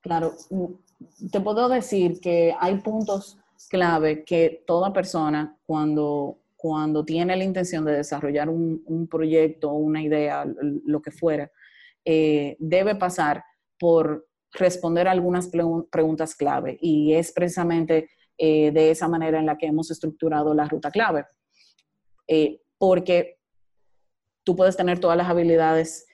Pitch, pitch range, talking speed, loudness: 165 Hz, 155-180 Hz, 135 wpm, -23 LUFS